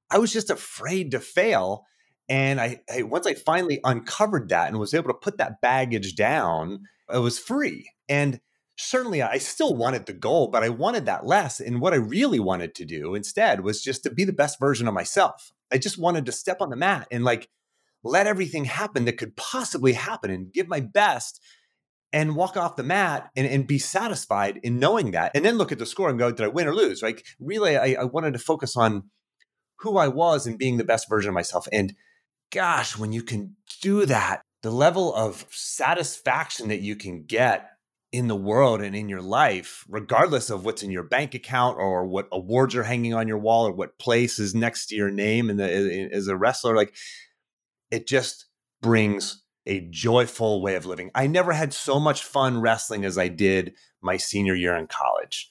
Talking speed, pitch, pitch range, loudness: 210 wpm, 120 Hz, 105-145 Hz, -24 LUFS